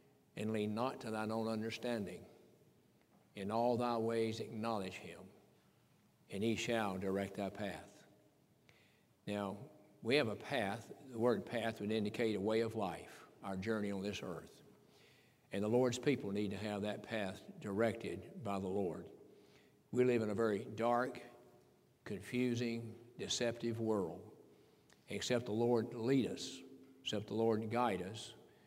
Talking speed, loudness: 145 wpm, -39 LUFS